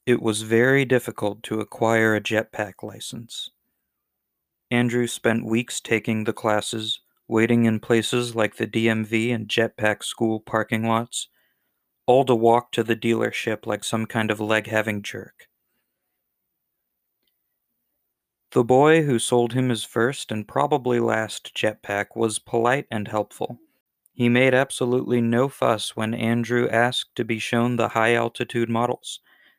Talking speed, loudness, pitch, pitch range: 140 wpm, -22 LUFS, 115 Hz, 110-120 Hz